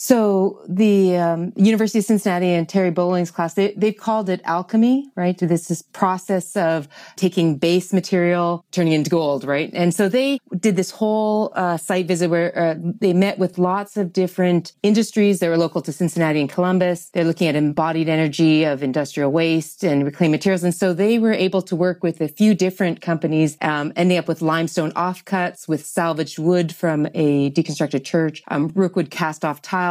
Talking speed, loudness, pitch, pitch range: 190 wpm, -19 LUFS, 175 Hz, 160-190 Hz